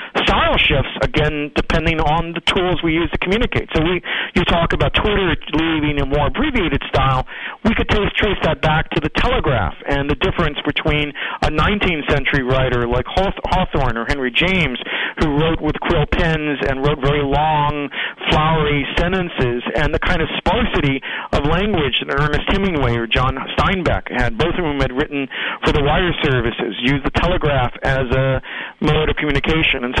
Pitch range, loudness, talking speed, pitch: 135-165 Hz, -18 LUFS, 180 wpm, 150 Hz